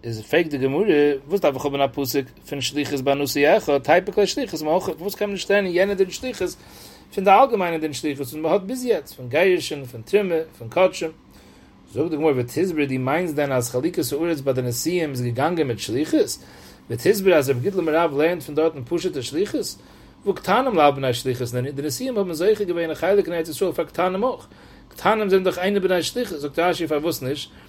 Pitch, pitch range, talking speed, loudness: 160 Hz, 140-190 Hz, 215 wpm, -22 LUFS